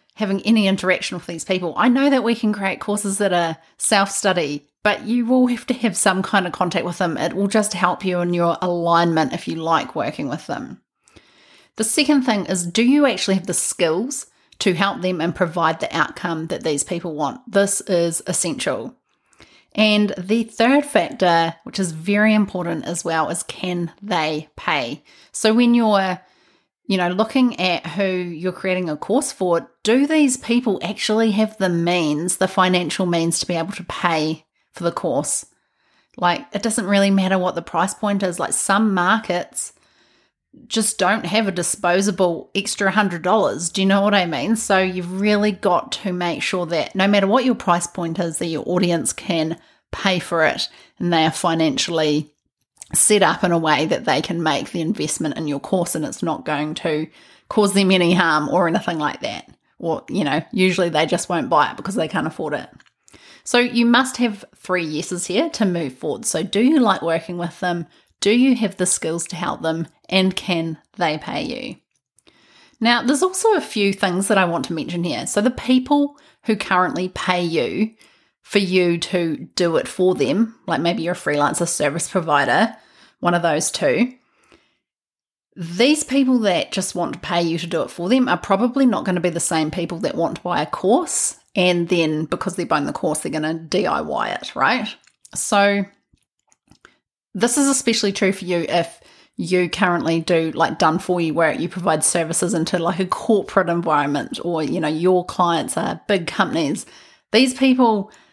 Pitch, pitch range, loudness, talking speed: 185 Hz, 170-210 Hz, -19 LUFS, 190 wpm